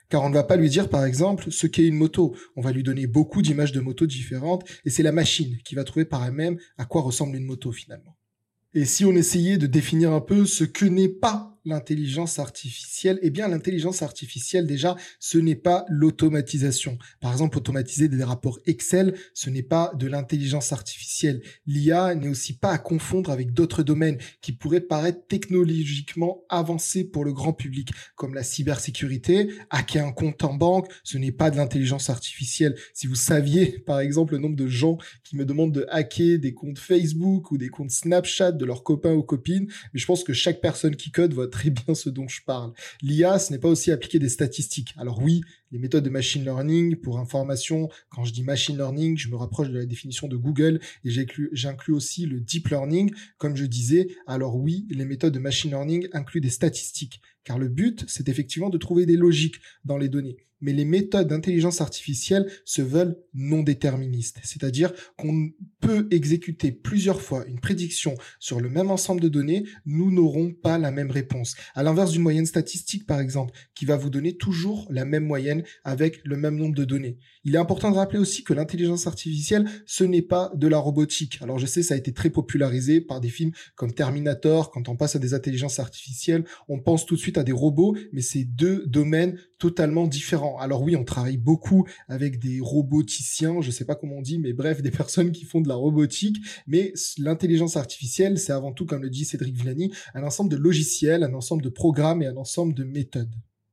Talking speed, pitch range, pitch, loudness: 205 wpm, 135-170 Hz, 150 Hz, -24 LUFS